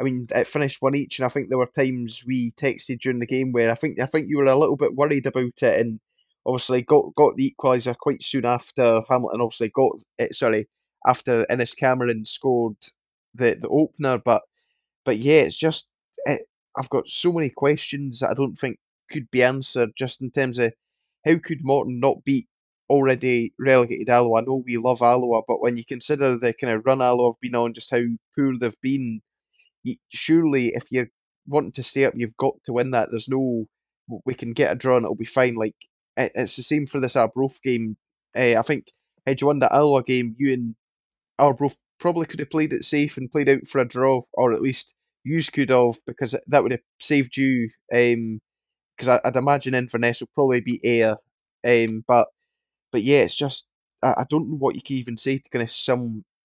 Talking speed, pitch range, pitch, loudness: 210 wpm, 120-140 Hz, 130 Hz, -22 LUFS